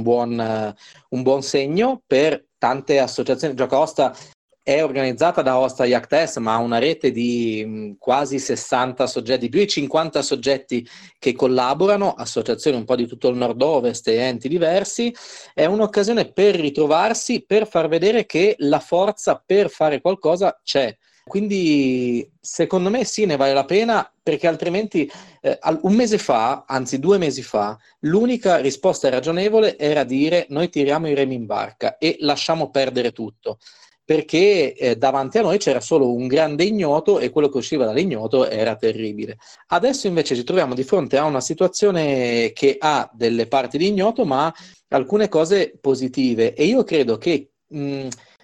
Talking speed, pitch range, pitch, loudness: 160 wpm, 130-190 Hz, 145 Hz, -19 LUFS